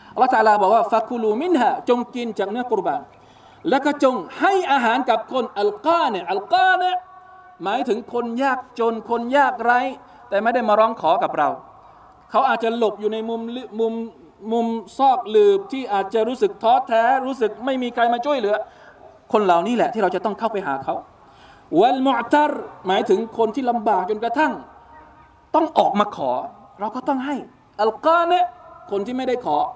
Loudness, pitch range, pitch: -20 LUFS, 225-295 Hz, 245 Hz